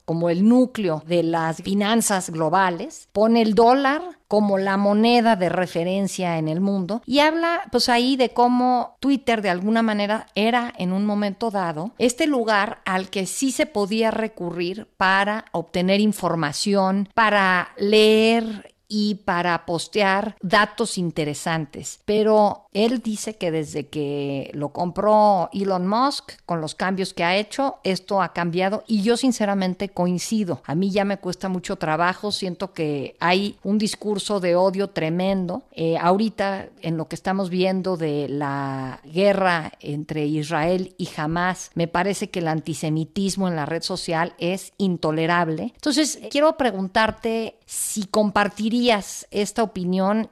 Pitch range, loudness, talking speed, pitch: 175-215 Hz, -22 LUFS, 145 wpm, 195 Hz